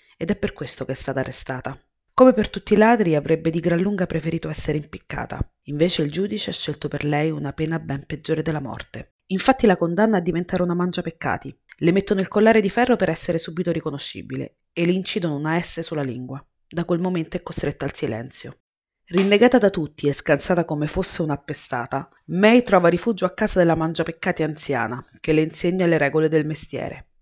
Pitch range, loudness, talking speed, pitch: 150-185 Hz, -21 LUFS, 195 wpm, 165 Hz